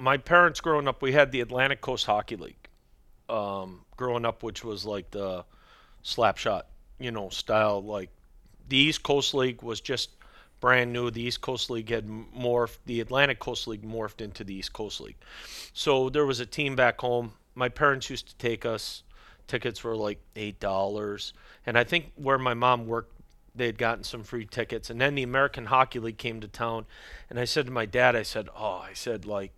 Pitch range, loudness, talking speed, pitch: 105-130 Hz, -28 LUFS, 200 wpm, 120 Hz